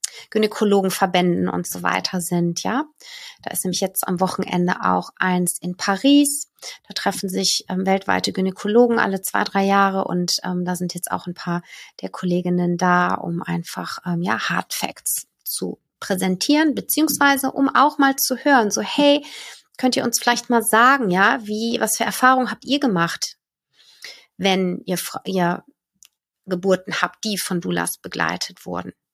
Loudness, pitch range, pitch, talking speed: -20 LUFS, 180-245 Hz, 195 Hz, 160 wpm